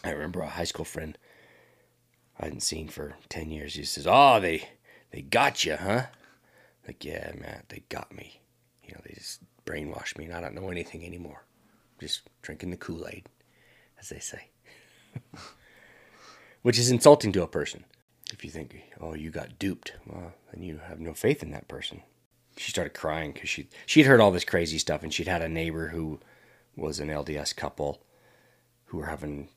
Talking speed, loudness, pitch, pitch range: 190 wpm, -27 LUFS, 80 Hz, 75-95 Hz